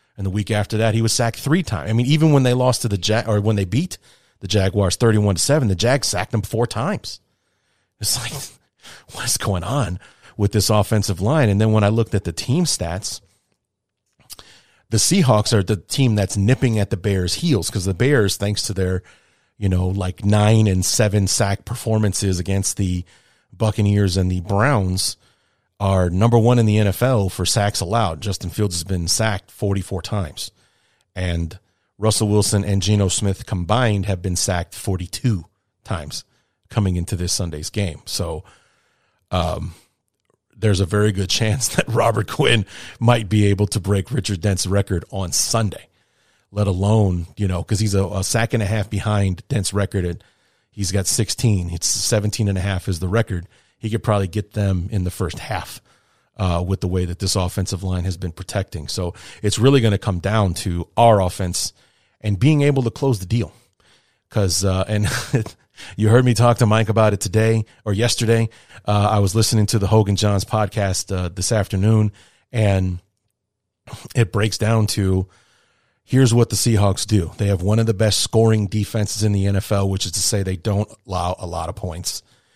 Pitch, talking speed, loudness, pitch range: 105 Hz, 185 wpm, -19 LUFS, 95-110 Hz